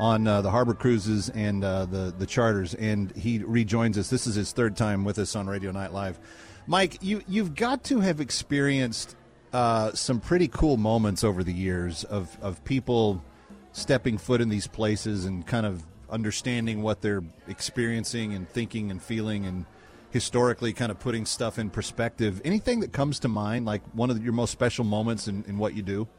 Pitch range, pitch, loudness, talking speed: 100-120 Hz, 110 Hz, -27 LUFS, 195 wpm